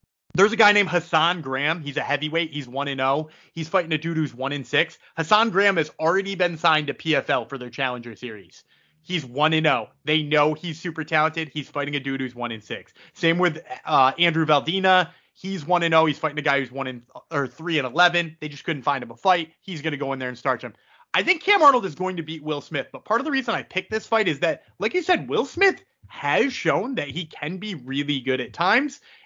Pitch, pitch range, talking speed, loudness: 160 Hz, 145-185 Hz, 225 wpm, -23 LUFS